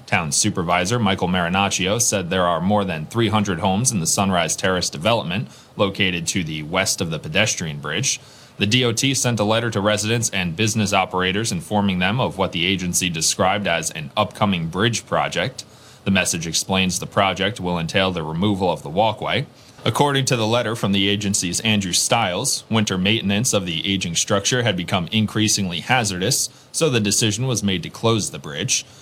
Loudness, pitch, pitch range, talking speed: -20 LUFS, 100 Hz, 95-115 Hz, 180 wpm